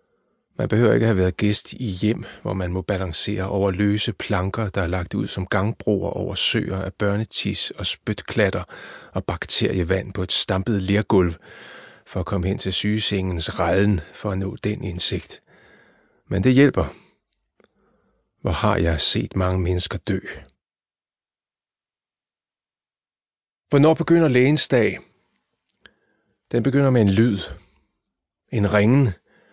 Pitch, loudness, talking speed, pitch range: 100 Hz, -21 LUFS, 135 wpm, 95-110 Hz